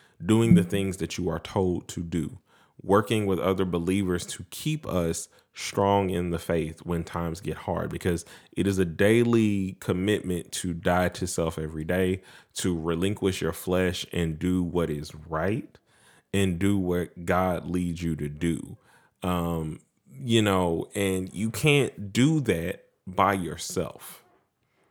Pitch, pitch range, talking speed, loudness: 90 Hz, 85-100 Hz, 150 wpm, -27 LUFS